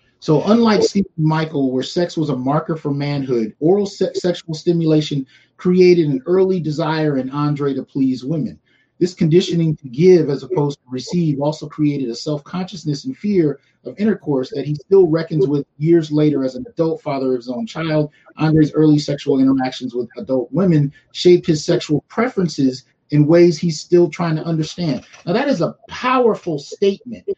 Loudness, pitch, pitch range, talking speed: -17 LUFS, 155 Hz, 140-175 Hz, 175 wpm